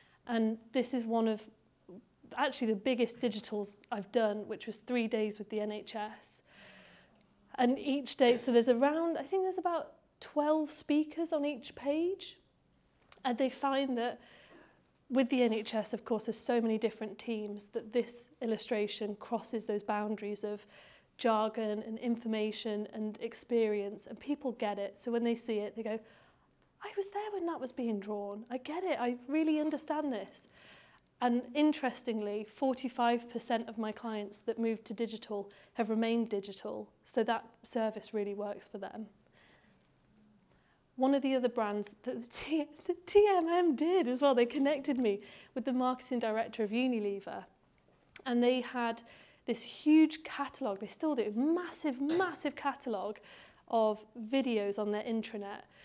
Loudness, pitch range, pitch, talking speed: -34 LUFS, 215-270 Hz, 235 Hz, 155 wpm